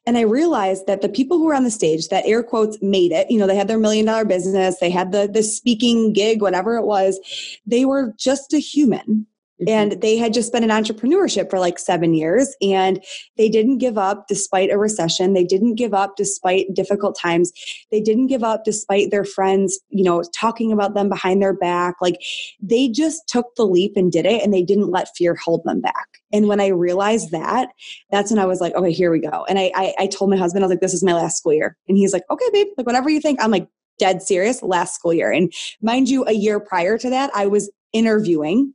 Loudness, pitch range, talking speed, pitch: -18 LUFS, 190-230 Hz, 235 wpm, 205 Hz